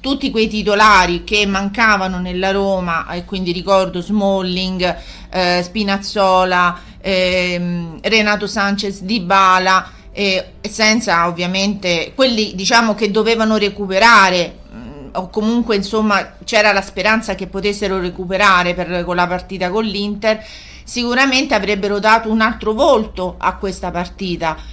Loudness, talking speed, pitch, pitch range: -15 LUFS, 125 wpm, 195 Hz, 180-215 Hz